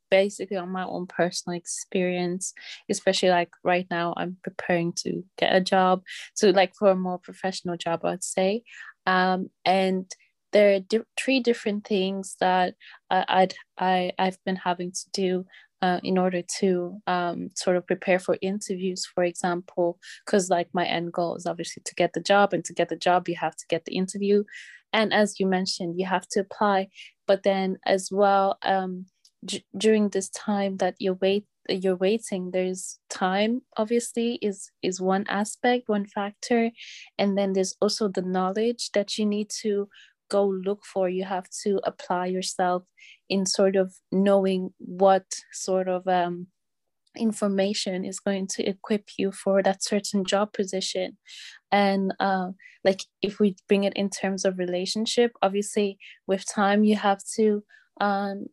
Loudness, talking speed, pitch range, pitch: -25 LUFS, 165 wpm, 185-200 Hz, 190 Hz